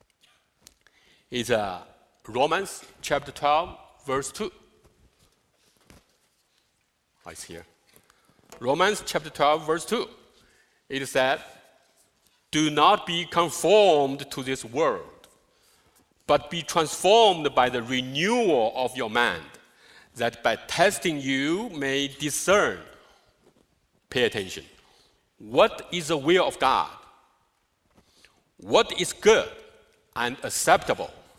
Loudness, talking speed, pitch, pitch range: -24 LUFS, 100 wpm, 170 Hz, 145-220 Hz